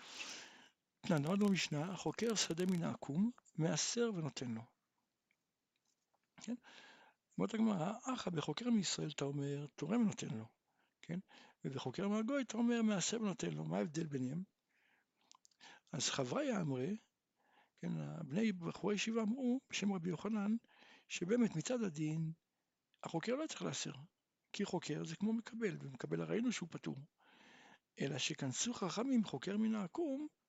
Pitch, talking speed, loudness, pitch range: 195 Hz, 130 wpm, -40 LUFS, 155-225 Hz